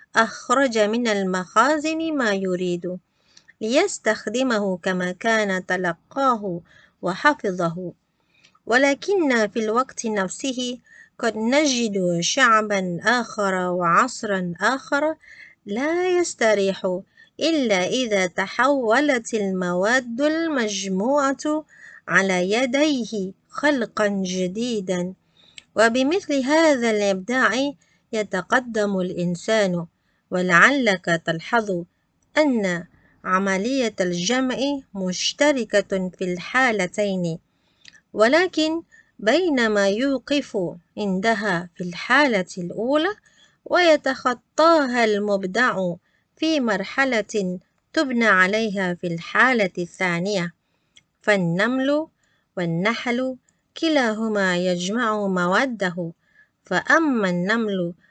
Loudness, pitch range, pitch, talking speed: -21 LUFS, 185-270 Hz, 215 Hz, 70 wpm